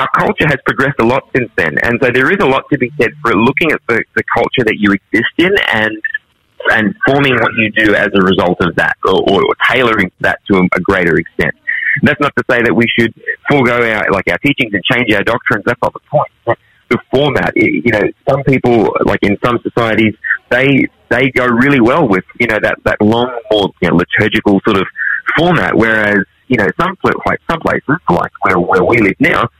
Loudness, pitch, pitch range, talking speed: -12 LUFS, 110 Hz, 105-125 Hz, 220 wpm